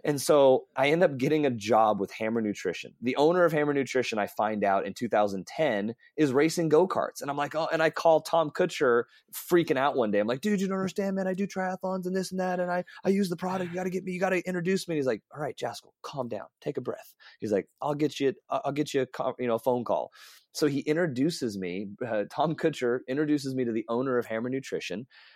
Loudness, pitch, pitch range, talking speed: -28 LUFS, 150 Hz, 125-180 Hz, 255 wpm